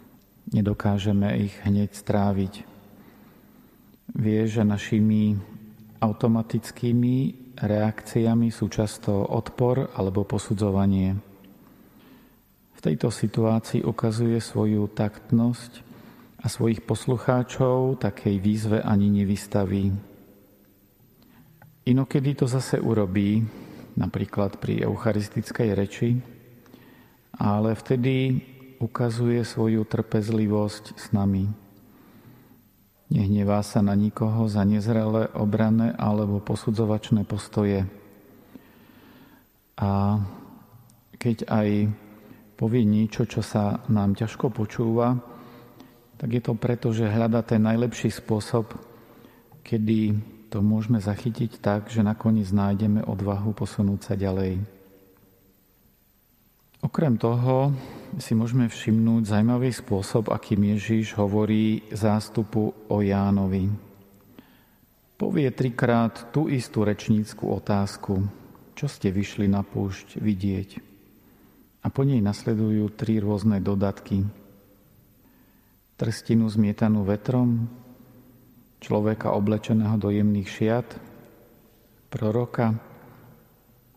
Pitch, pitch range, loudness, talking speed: 110 Hz, 105-120 Hz, -25 LUFS, 90 wpm